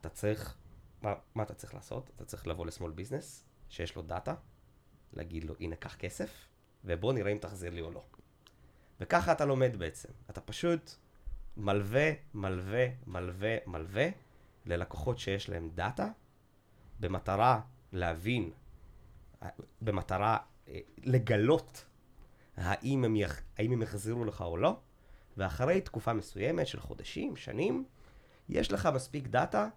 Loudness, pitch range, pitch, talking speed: -35 LUFS, 95-125 Hz, 105 Hz, 130 wpm